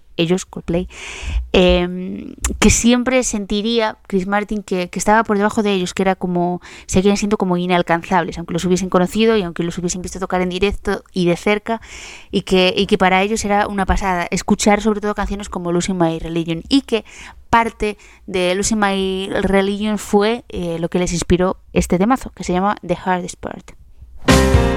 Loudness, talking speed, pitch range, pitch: -17 LUFS, 180 wpm, 180-210 Hz, 190 Hz